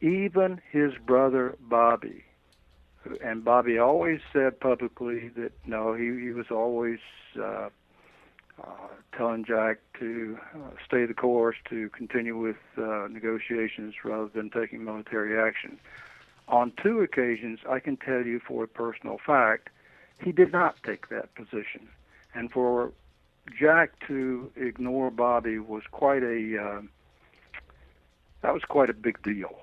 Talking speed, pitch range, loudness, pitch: 135 wpm, 110-125 Hz, -28 LUFS, 115 Hz